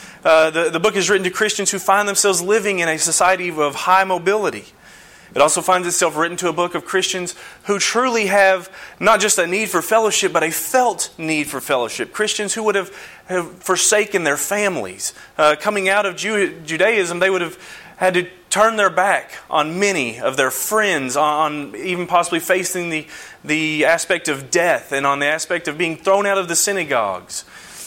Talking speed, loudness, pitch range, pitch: 195 wpm, -17 LUFS, 165-200 Hz, 185 Hz